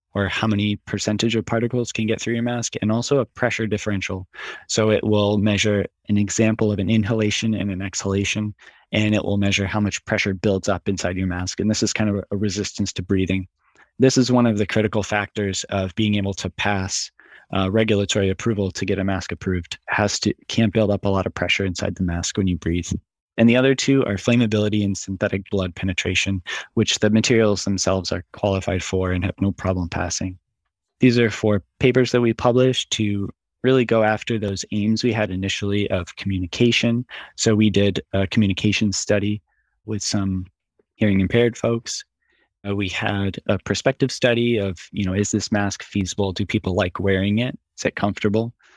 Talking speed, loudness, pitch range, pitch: 190 wpm, -21 LUFS, 95-110 Hz, 105 Hz